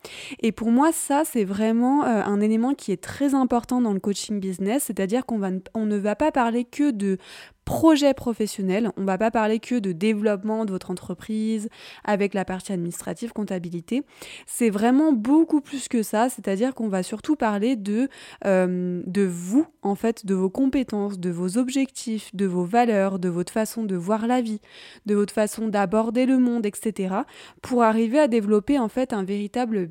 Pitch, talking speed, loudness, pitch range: 220 Hz, 190 wpm, -23 LUFS, 200-250 Hz